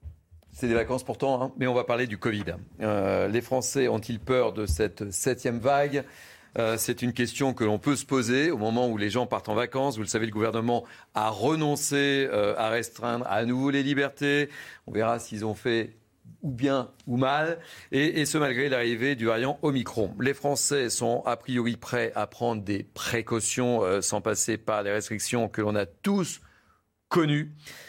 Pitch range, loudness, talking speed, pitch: 110-140 Hz, -27 LUFS, 190 wpm, 120 Hz